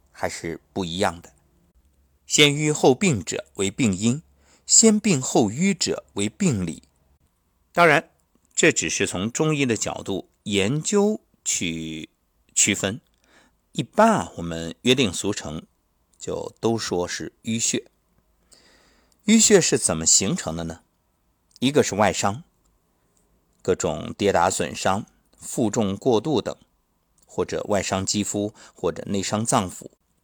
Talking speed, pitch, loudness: 180 characters per minute, 105 Hz, -22 LUFS